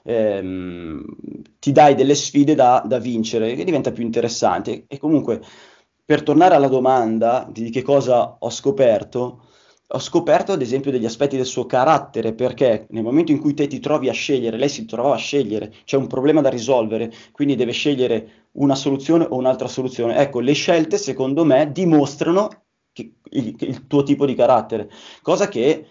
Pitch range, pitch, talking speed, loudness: 115-145 Hz, 130 Hz, 175 wpm, -18 LUFS